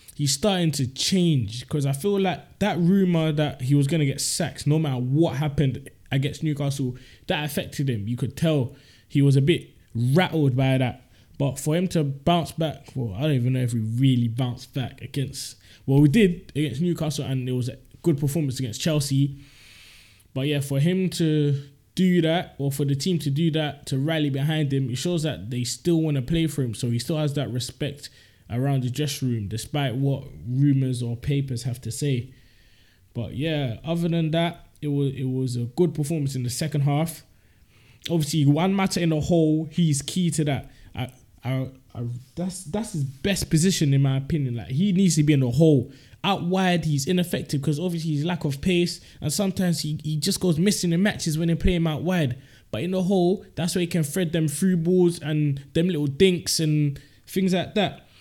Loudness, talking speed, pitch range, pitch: -24 LUFS, 210 wpm, 130-165 Hz, 145 Hz